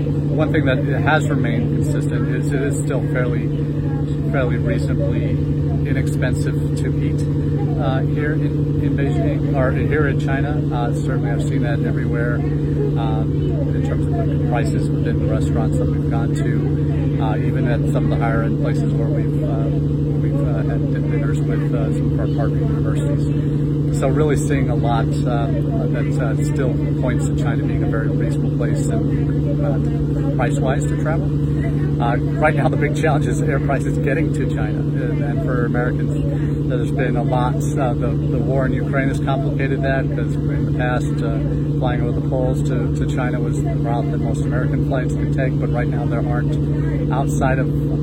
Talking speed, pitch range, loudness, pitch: 180 wpm, 145-150 Hz, -19 LUFS, 145 Hz